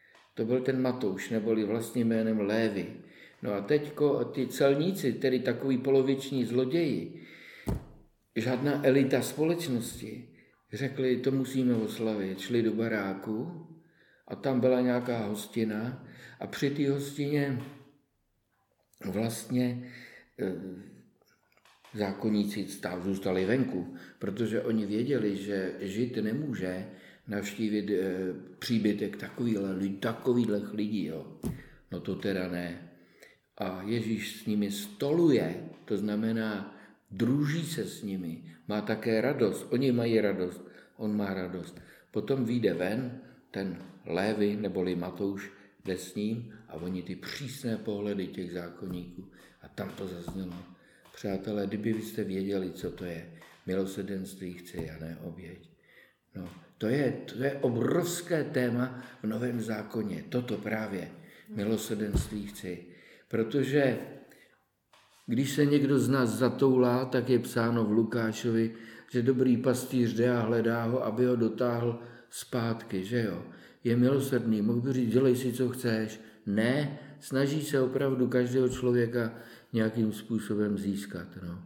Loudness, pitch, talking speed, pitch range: -31 LUFS, 115 Hz, 120 wpm, 100-125 Hz